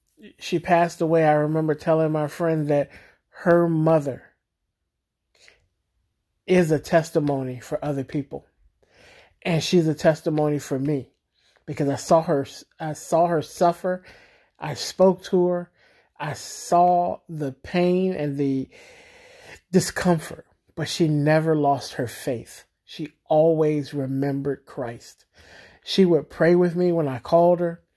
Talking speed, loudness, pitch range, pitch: 130 wpm, -22 LUFS, 145-175 Hz, 160 Hz